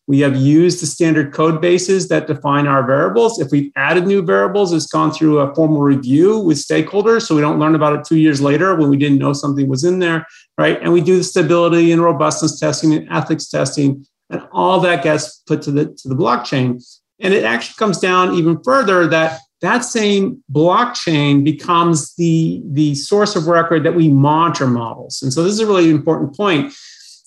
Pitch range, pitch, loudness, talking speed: 145-175 Hz, 160 Hz, -14 LUFS, 200 wpm